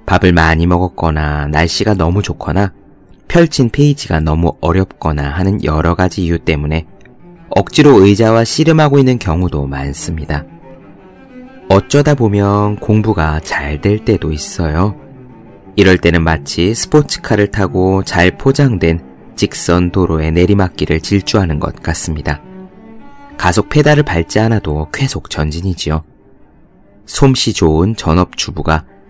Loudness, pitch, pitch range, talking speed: -13 LUFS, 95 Hz, 80-115 Hz, 280 characters per minute